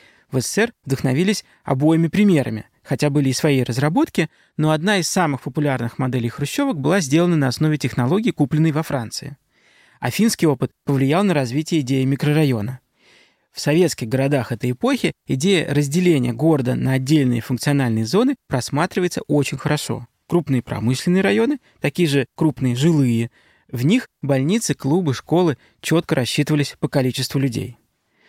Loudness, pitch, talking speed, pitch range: -19 LUFS, 145 Hz, 140 wpm, 130-165 Hz